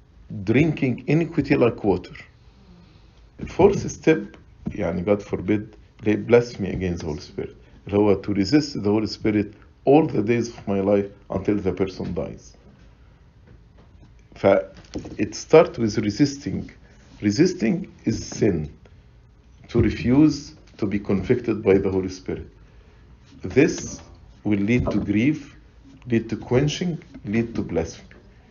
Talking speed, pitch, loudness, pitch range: 120 wpm, 105 Hz, -22 LUFS, 100-120 Hz